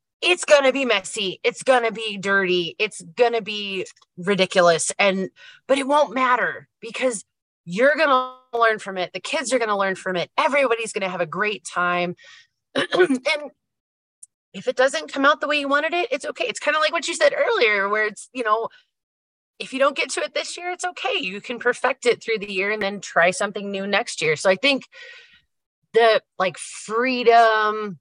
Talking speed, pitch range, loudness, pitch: 210 wpm, 195-285 Hz, -21 LUFS, 230 Hz